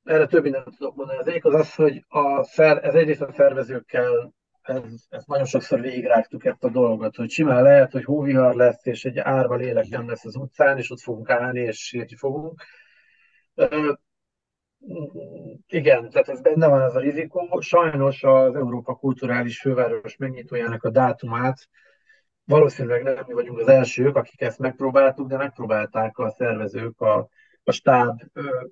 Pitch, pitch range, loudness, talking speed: 135 Hz, 125-170 Hz, -21 LUFS, 160 wpm